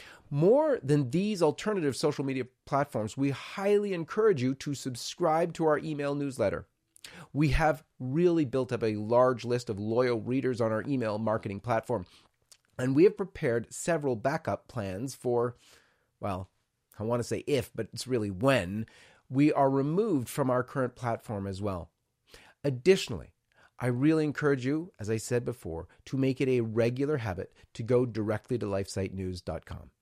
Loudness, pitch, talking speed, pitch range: -30 LUFS, 125 Hz, 160 wpm, 110-145 Hz